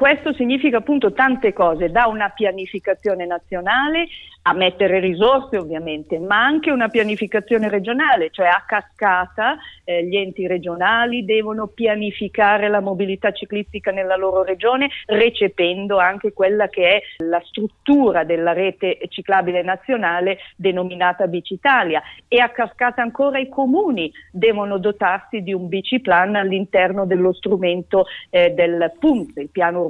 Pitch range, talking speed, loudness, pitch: 180-225 Hz, 130 wpm, -18 LUFS, 200 Hz